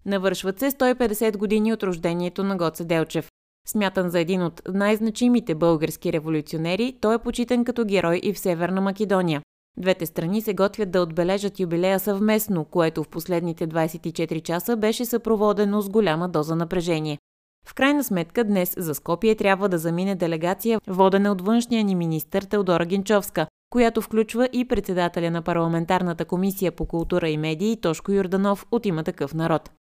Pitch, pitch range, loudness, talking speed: 190 Hz, 170-215 Hz, -23 LUFS, 155 wpm